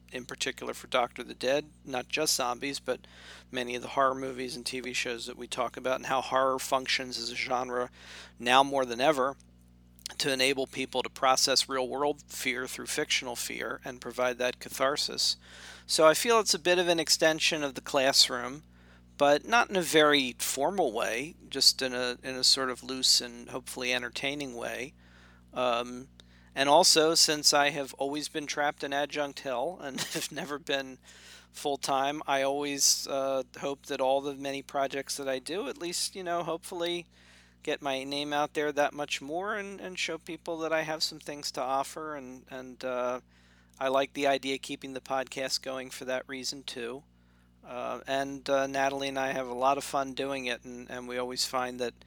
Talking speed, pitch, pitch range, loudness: 195 wpm, 135 Hz, 125-145 Hz, -29 LUFS